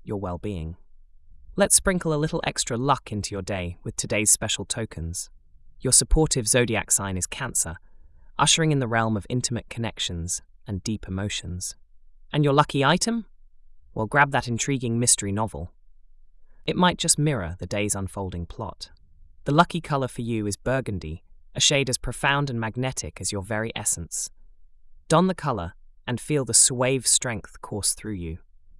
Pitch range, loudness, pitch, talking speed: 85-135 Hz, -23 LUFS, 110 Hz, 165 wpm